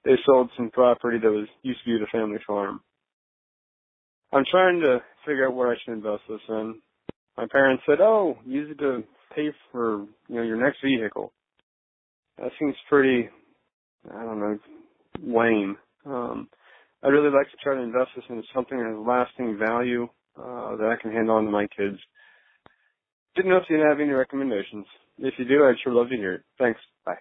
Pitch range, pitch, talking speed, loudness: 110-140 Hz, 125 Hz, 190 wpm, -24 LUFS